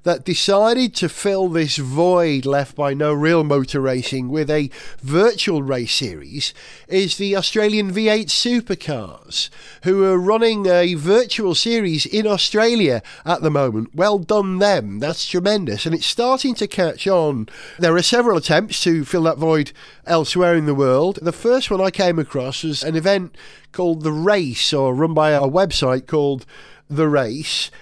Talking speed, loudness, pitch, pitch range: 165 wpm, -18 LUFS, 170 Hz, 150-200 Hz